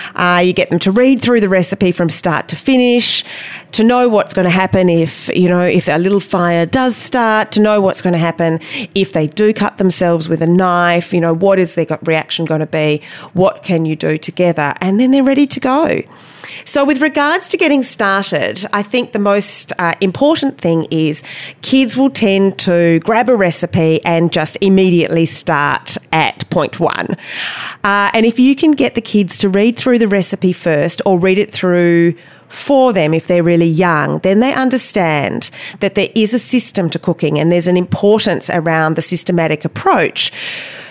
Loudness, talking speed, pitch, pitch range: -13 LUFS, 195 wpm, 185 Hz, 170-220 Hz